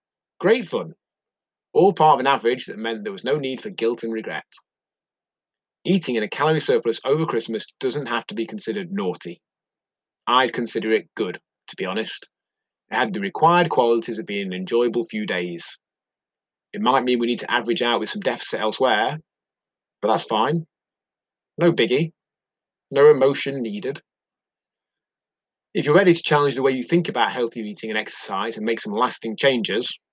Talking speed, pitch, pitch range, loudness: 175 wpm, 120 Hz, 110-155 Hz, -22 LUFS